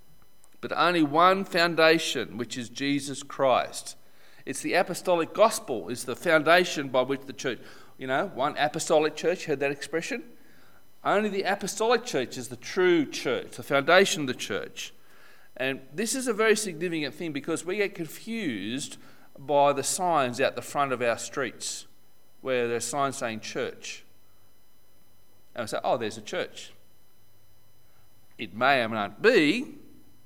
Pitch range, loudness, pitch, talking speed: 125-190 Hz, -26 LUFS, 150 Hz, 155 wpm